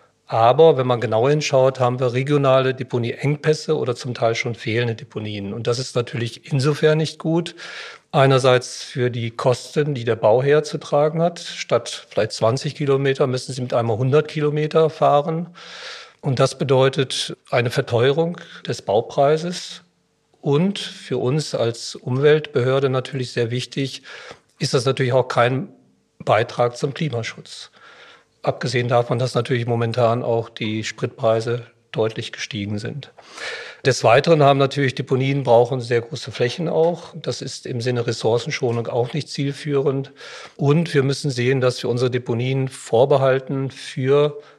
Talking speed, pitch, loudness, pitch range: 140 wpm, 130 Hz, -20 LUFS, 120-145 Hz